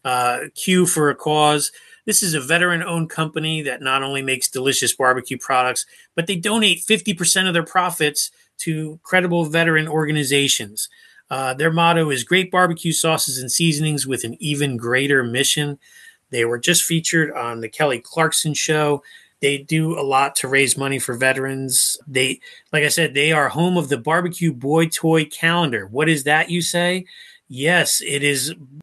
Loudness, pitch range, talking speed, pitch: -18 LUFS, 135-170 Hz, 170 wpm, 155 Hz